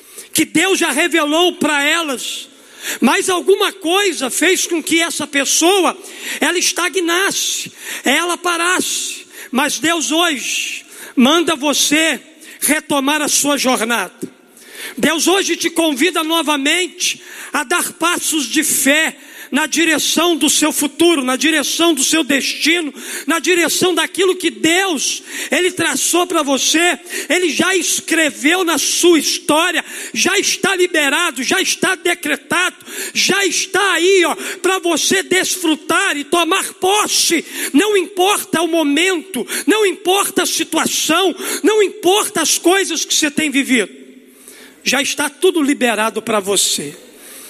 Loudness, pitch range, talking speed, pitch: -14 LUFS, 300-360 Hz, 125 wpm, 330 Hz